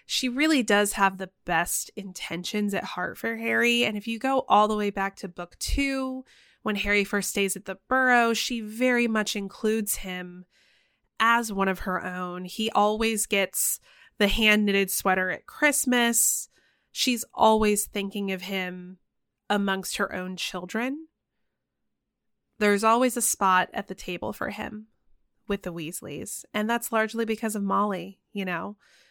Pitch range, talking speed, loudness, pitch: 185-225 Hz, 160 wpm, -25 LUFS, 205 Hz